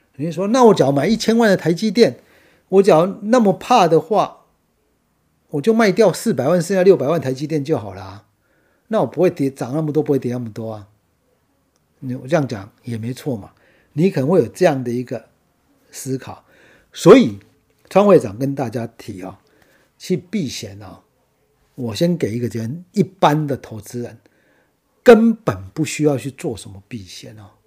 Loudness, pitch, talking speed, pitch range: -17 LUFS, 140 Hz, 260 characters per minute, 115-180 Hz